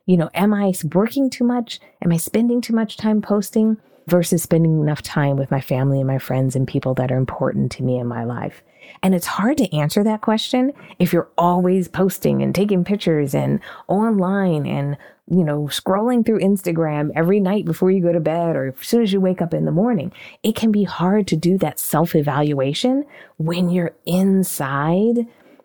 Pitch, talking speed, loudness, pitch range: 180 Hz, 200 wpm, -19 LUFS, 150-210 Hz